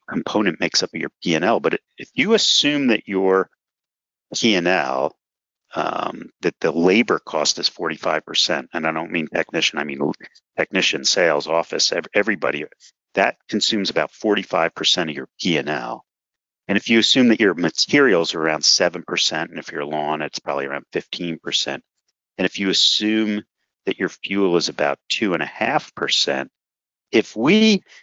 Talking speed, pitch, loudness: 155 wpm, 95 Hz, -19 LUFS